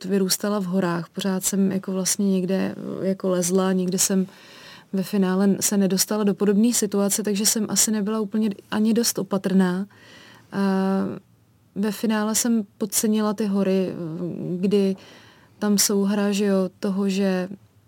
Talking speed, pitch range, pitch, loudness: 140 wpm, 190-210 Hz, 195 Hz, -22 LUFS